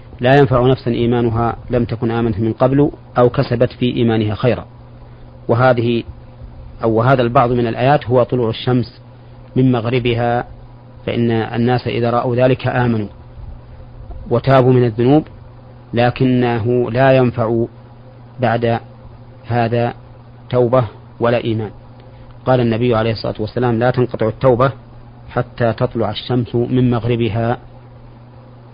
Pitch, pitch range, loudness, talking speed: 120 Hz, 120-125 Hz, -16 LUFS, 115 wpm